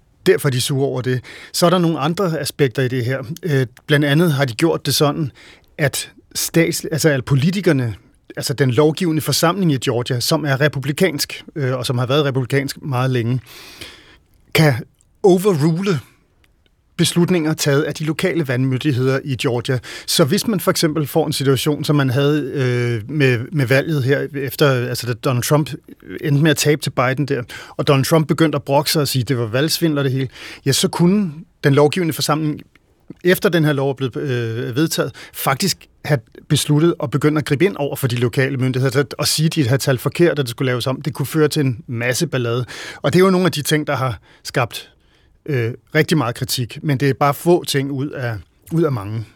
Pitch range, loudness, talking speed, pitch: 130-155 Hz, -18 LUFS, 205 wpm, 145 Hz